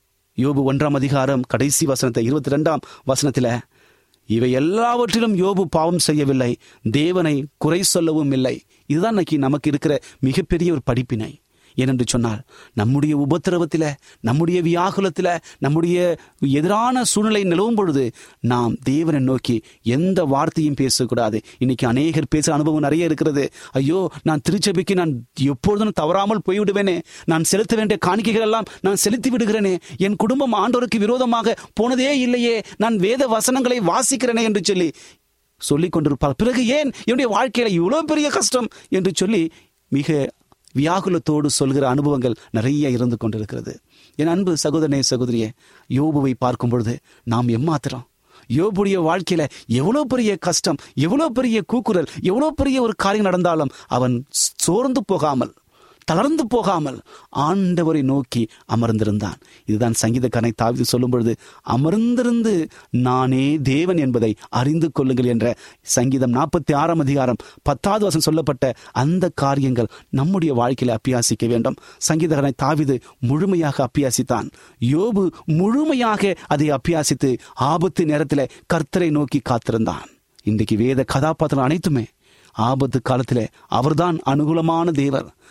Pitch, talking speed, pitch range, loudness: 150 Hz, 120 wpm, 130-190 Hz, -19 LUFS